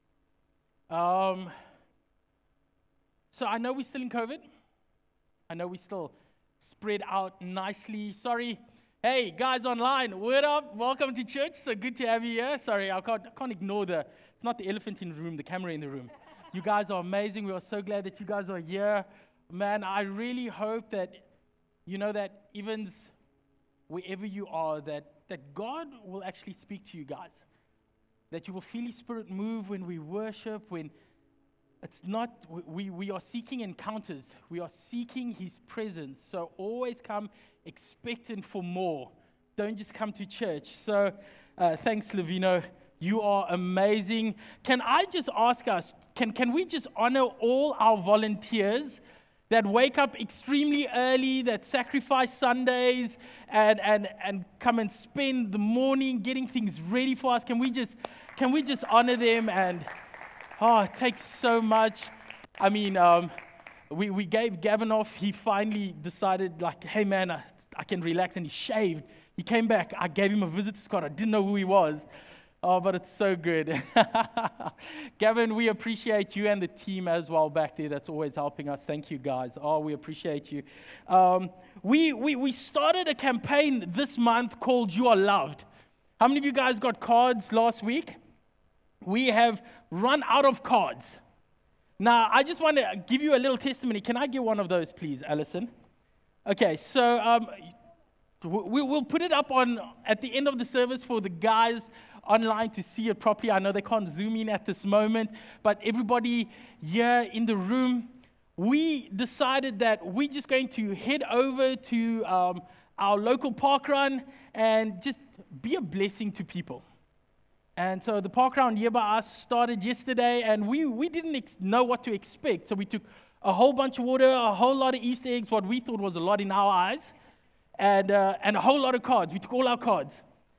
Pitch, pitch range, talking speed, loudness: 220 Hz, 190-245 Hz, 180 wpm, -28 LUFS